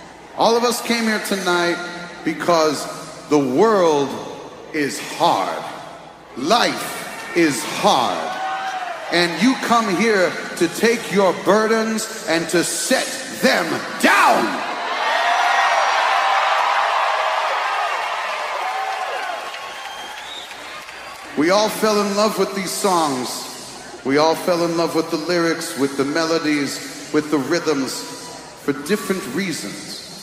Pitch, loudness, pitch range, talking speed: 175 Hz, -19 LUFS, 160-220 Hz, 105 wpm